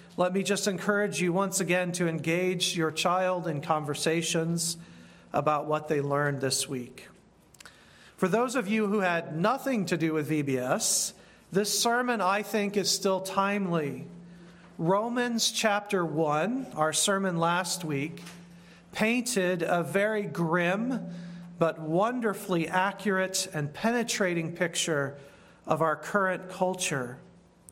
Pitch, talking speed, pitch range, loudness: 180 Hz, 125 wpm, 165-200 Hz, -28 LUFS